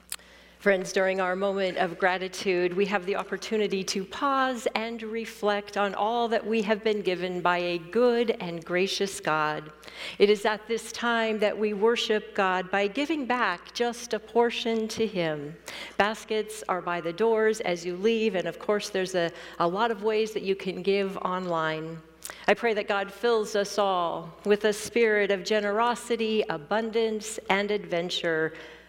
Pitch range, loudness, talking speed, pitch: 180-220 Hz, -27 LUFS, 170 wpm, 205 Hz